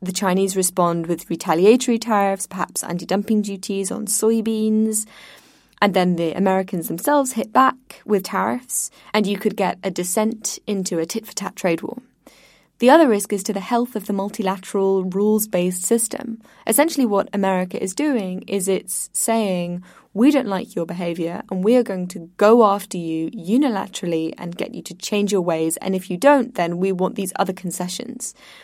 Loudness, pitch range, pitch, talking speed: -20 LUFS, 185-225 Hz, 200 Hz, 180 wpm